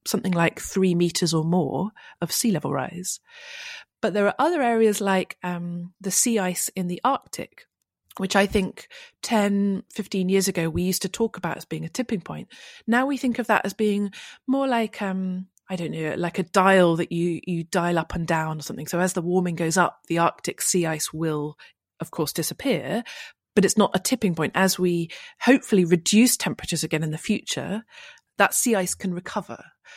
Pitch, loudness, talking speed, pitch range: 185 Hz, -24 LUFS, 200 wpm, 175-215 Hz